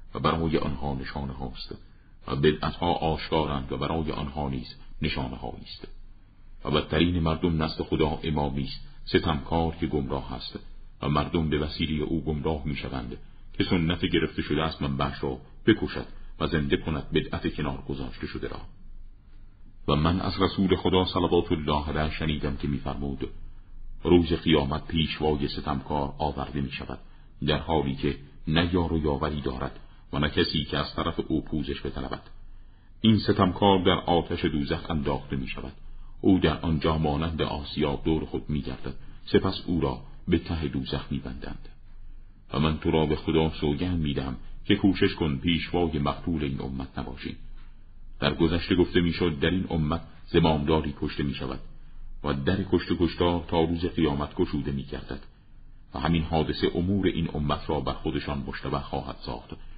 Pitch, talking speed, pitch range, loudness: 80 Hz, 160 wpm, 70-85 Hz, -27 LUFS